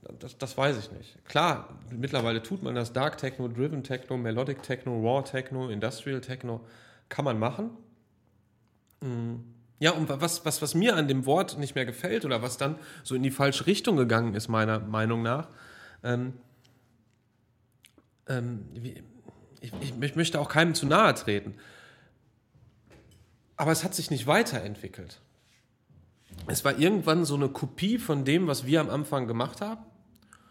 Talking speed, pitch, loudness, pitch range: 150 wpm, 130 Hz, -28 LUFS, 115-150 Hz